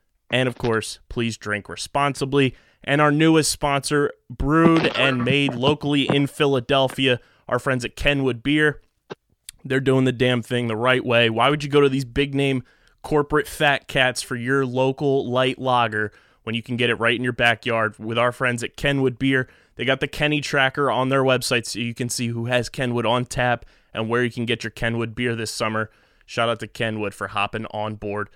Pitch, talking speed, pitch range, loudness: 125 Hz, 200 wpm, 115-140 Hz, -21 LUFS